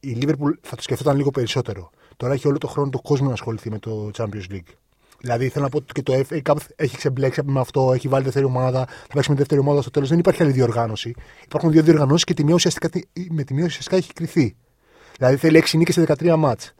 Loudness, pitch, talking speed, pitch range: -20 LUFS, 140 Hz, 240 wpm, 130-155 Hz